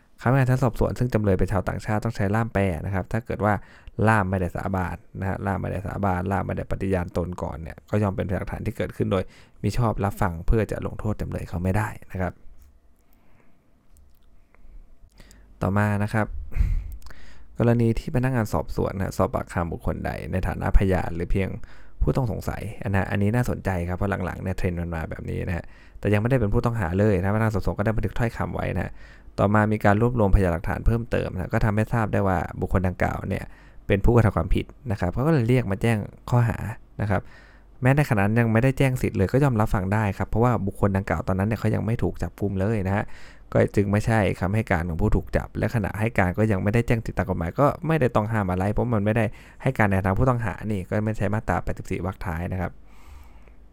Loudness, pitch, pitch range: -25 LUFS, 100 Hz, 90-110 Hz